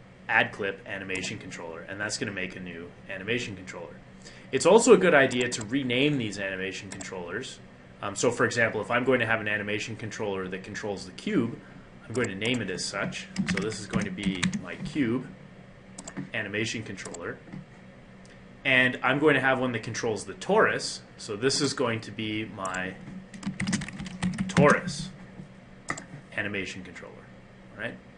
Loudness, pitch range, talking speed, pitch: -27 LUFS, 85-125 Hz, 165 wpm, 105 Hz